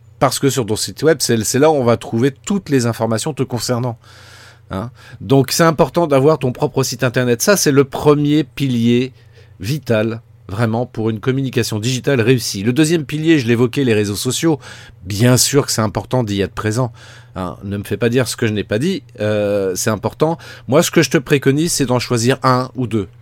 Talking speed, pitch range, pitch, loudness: 210 wpm, 110-140 Hz, 125 Hz, -16 LUFS